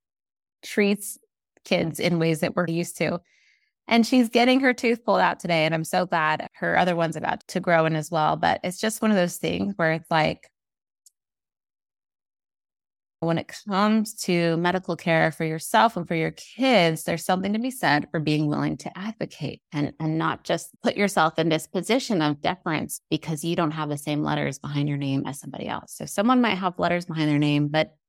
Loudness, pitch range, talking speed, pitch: -24 LUFS, 155-200 Hz, 200 wpm, 170 Hz